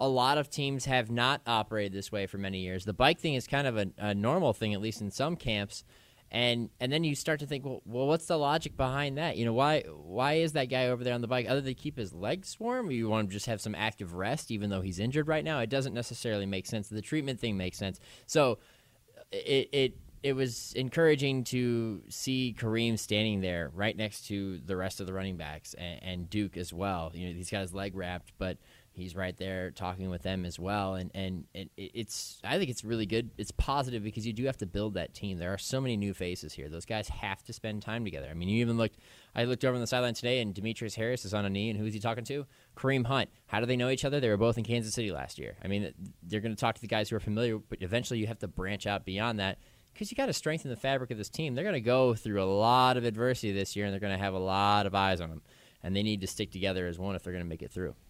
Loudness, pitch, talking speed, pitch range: -32 LUFS, 110 Hz, 275 wpm, 100-125 Hz